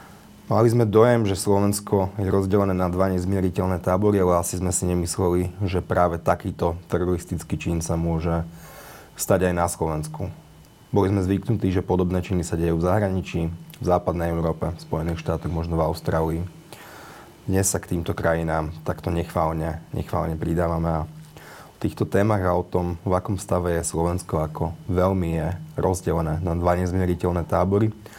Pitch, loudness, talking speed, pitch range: 90 Hz, -23 LUFS, 160 wpm, 85-95 Hz